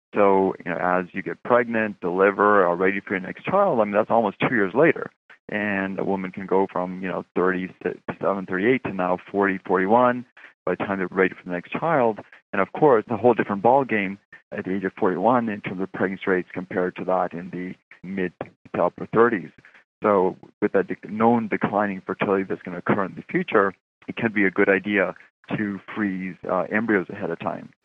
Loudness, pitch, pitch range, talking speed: -23 LUFS, 95 Hz, 90-105 Hz, 210 wpm